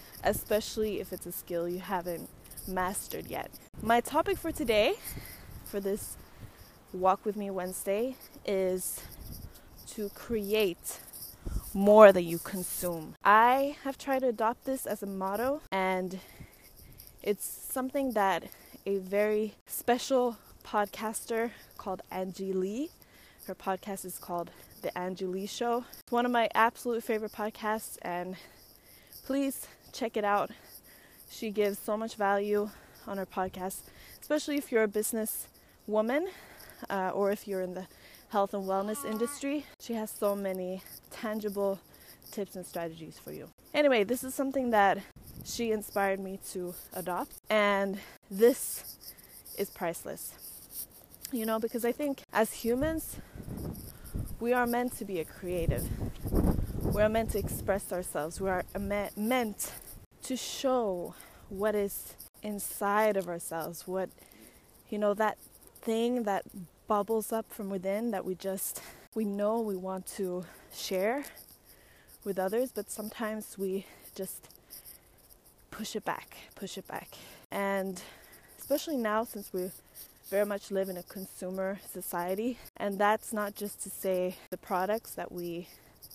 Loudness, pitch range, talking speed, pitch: -32 LUFS, 190-225 Hz, 140 wpm, 205 Hz